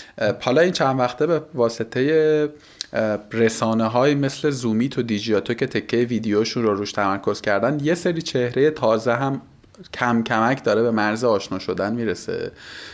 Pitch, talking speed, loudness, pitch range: 120 Hz, 150 wpm, -21 LUFS, 110-145 Hz